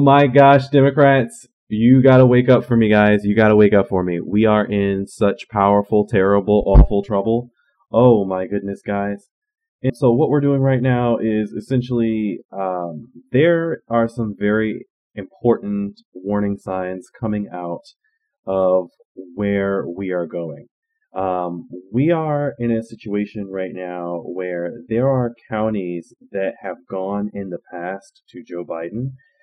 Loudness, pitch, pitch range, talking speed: -18 LUFS, 105 Hz, 95-125 Hz, 155 wpm